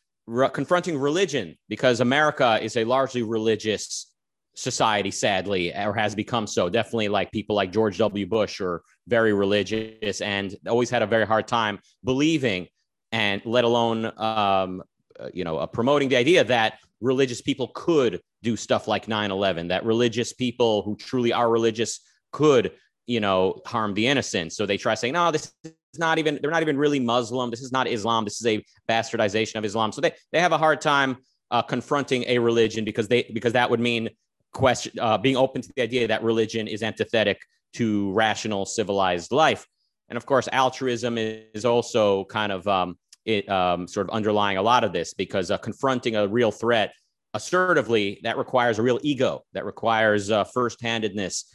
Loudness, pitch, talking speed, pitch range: -23 LUFS, 115 Hz, 180 wpm, 105-125 Hz